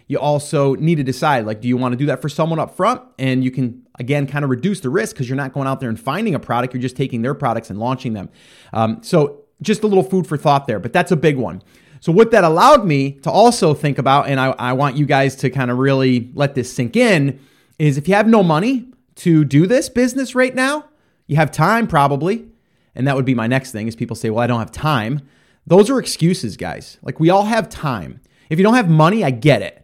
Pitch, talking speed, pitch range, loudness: 145 Hz, 255 wpm, 130-180 Hz, -16 LUFS